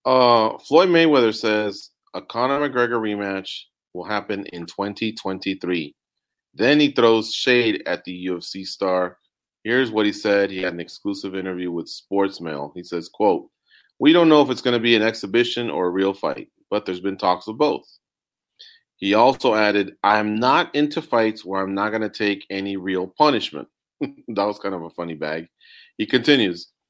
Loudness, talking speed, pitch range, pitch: -21 LUFS, 180 wpm, 95-120 Hz, 105 Hz